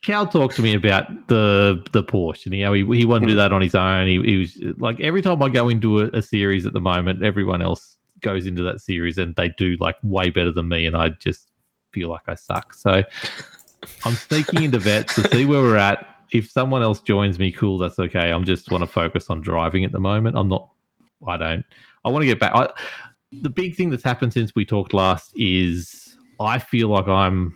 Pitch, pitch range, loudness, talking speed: 100 Hz, 90-120 Hz, -20 LUFS, 235 wpm